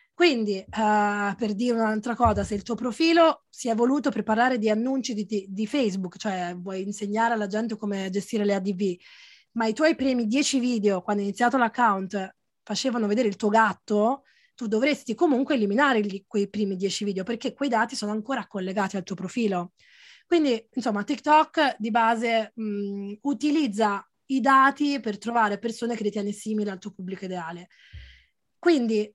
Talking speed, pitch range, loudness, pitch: 170 wpm, 205-250 Hz, -25 LUFS, 220 Hz